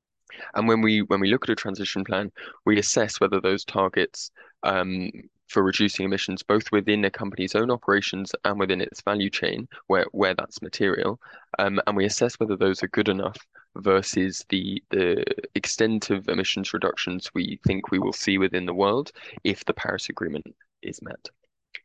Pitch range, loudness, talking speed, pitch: 95-105 Hz, -25 LUFS, 175 wpm, 100 Hz